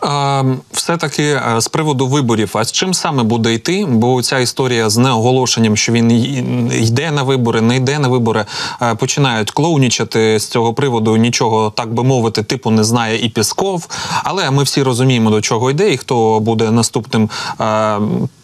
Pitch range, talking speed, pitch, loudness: 115-135 Hz, 165 wpm, 120 Hz, -14 LUFS